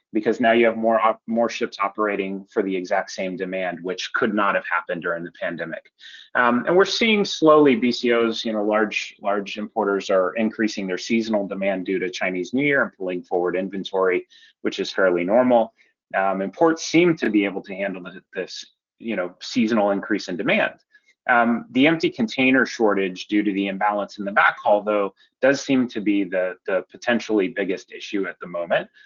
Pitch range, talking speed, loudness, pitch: 95-120 Hz, 185 wpm, -22 LUFS, 105 Hz